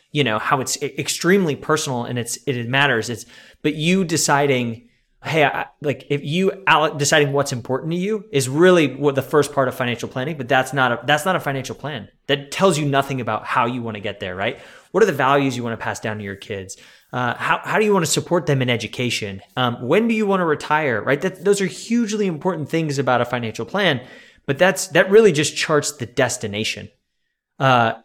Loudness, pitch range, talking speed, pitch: -19 LUFS, 120-165 Hz, 220 wpm, 140 Hz